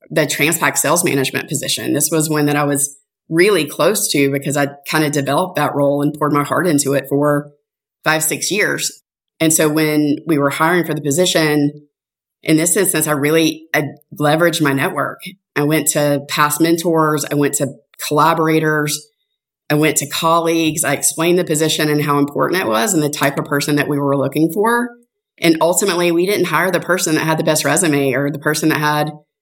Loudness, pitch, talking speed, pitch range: -15 LUFS, 150 Hz, 200 wpm, 145-160 Hz